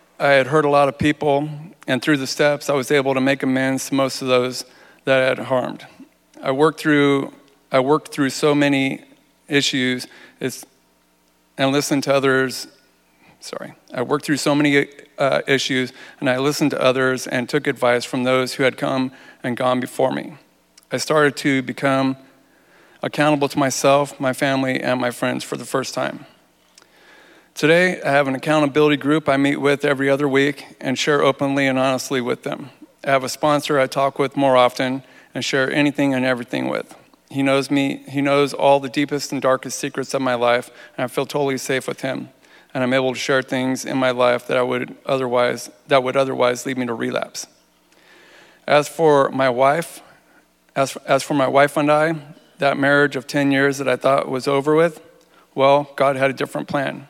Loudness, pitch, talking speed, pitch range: -19 LUFS, 135 Hz, 190 wpm, 130-145 Hz